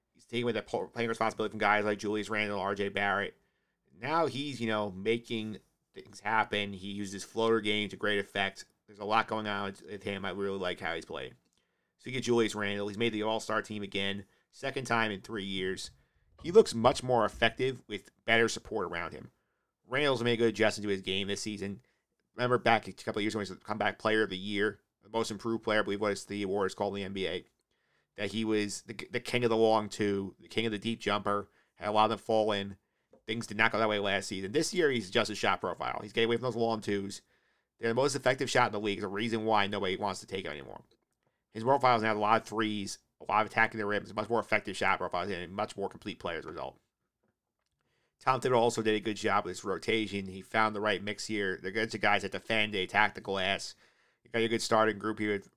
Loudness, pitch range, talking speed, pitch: -31 LUFS, 100-115 Hz, 250 wpm, 105 Hz